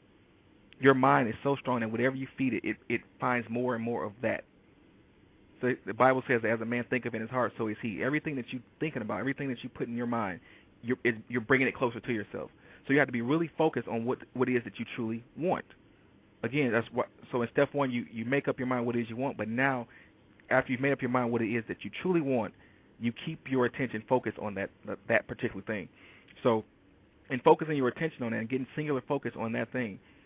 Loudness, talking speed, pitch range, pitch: -31 LUFS, 250 wpm, 115-135 Hz, 125 Hz